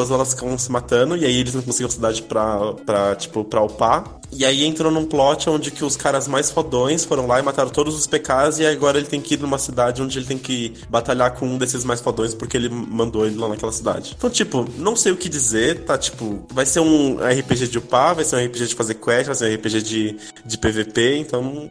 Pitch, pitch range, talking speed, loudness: 125 Hz, 115-145 Hz, 245 wpm, -19 LUFS